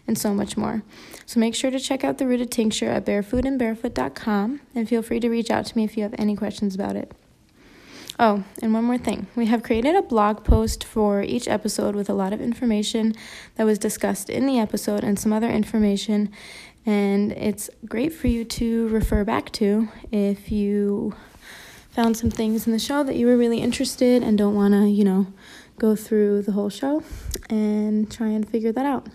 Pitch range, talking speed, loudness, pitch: 210-235 Hz, 205 wpm, -23 LUFS, 220 Hz